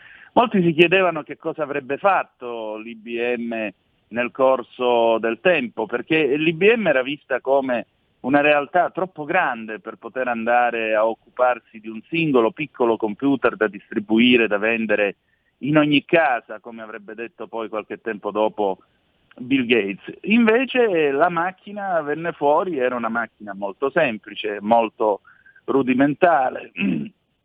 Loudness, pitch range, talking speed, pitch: -20 LUFS, 110-160 Hz, 130 wpm, 125 Hz